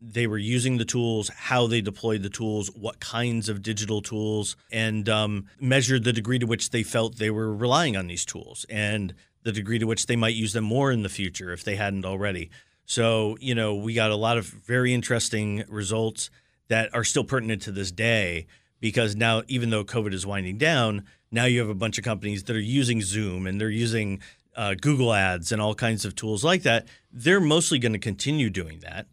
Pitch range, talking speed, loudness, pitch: 105-120 Hz, 215 wpm, -25 LUFS, 110 Hz